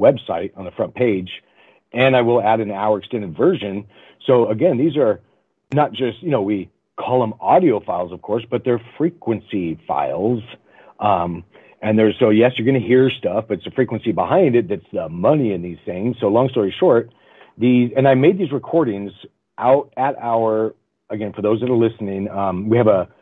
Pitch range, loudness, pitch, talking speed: 105-125 Hz, -18 LUFS, 115 Hz, 200 wpm